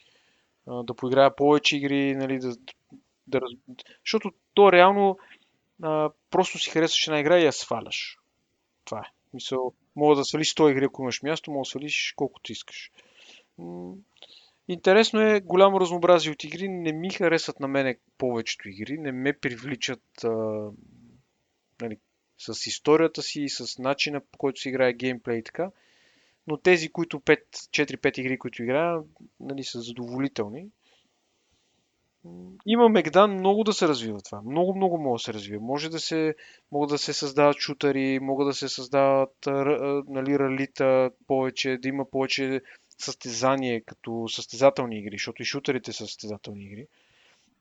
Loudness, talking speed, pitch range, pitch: -25 LUFS, 150 wpm, 125-155 Hz, 140 Hz